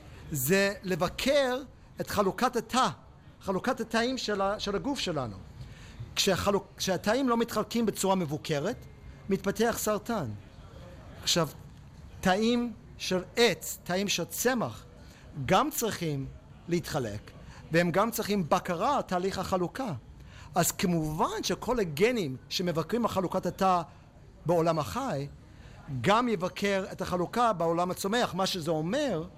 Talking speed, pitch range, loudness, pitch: 115 wpm, 165-215 Hz, -29 LUFS, 190 Hz